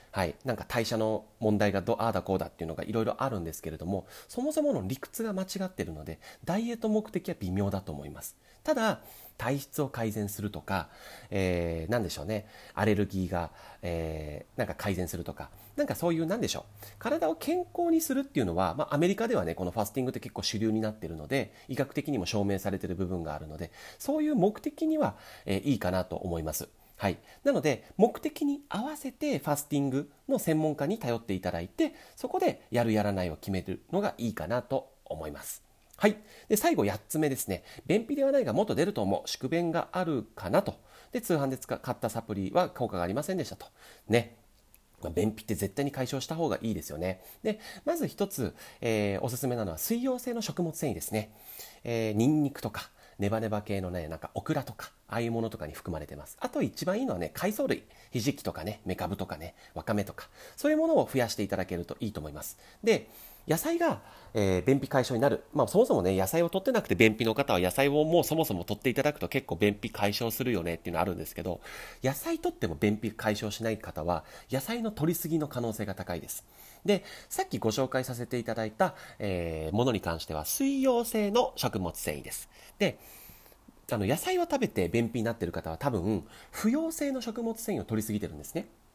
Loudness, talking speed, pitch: -31 LUFS, 425 characters per minute, 115 Hz